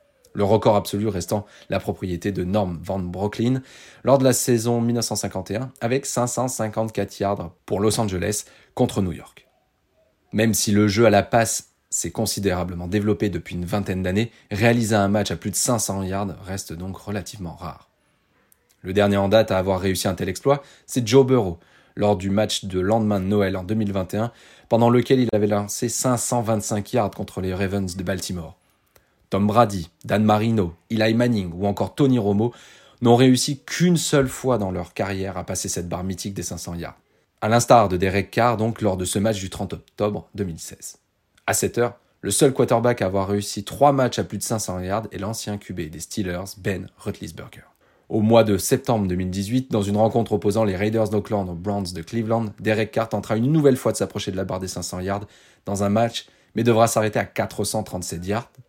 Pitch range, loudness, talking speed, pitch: 95-115 Hz, -22 LUFS, 190 wpm, 105 Hz